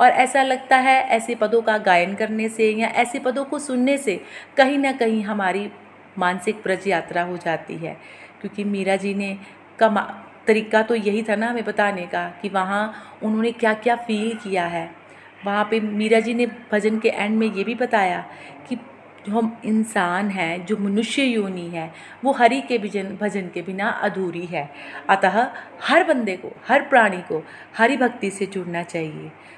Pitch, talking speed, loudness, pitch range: 215 Hz, 180 wpm, -21 LUFS, 195-235 Hz